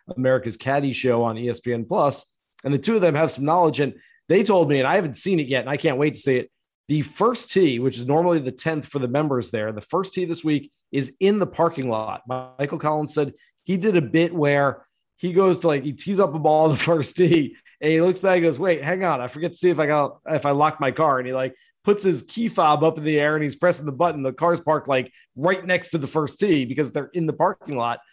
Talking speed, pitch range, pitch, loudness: 270 wpm, 135-175 Hz, 155 Hz, -22 LUFS